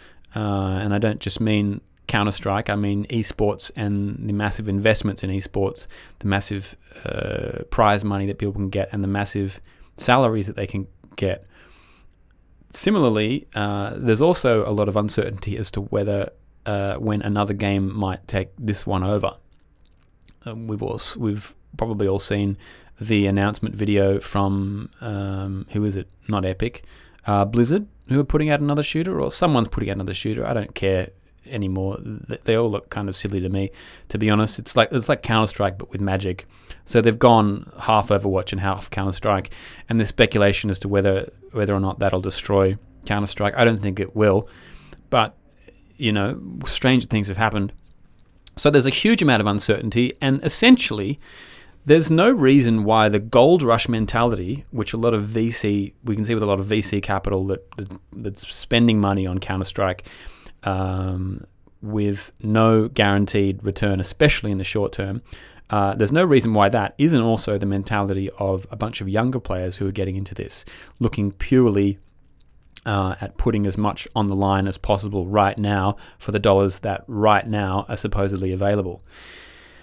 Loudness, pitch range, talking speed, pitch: -21 LUFS, 95-110 Hz, 175 wpm, 100 Hz